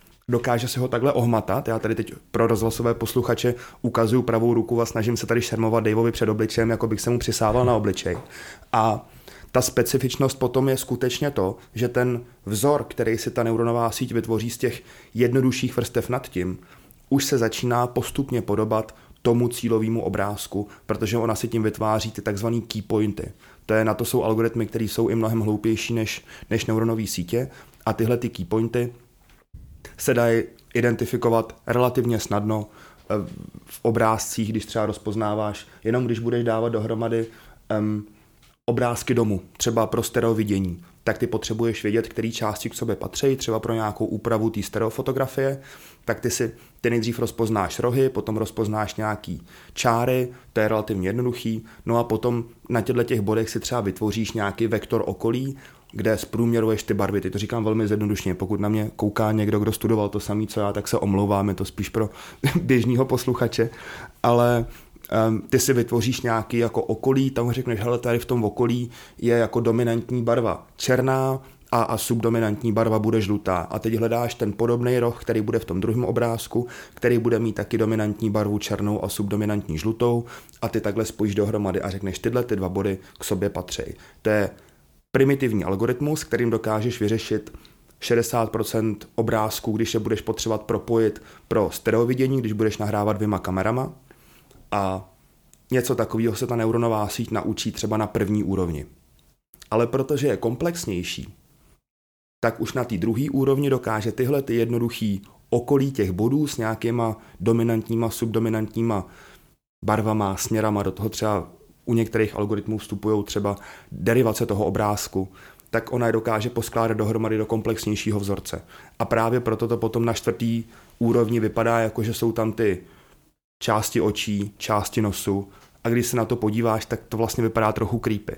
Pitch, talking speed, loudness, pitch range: 115 Hz, 160 wpm, -24 LUFS, 105-120 Hz